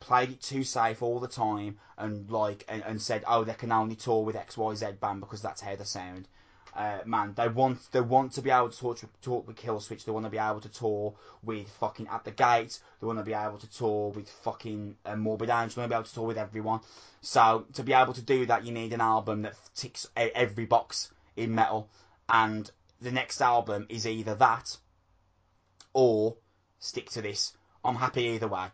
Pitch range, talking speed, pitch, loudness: 105-115 Hz, 220 wpm, 110 Hz, -30 LUFS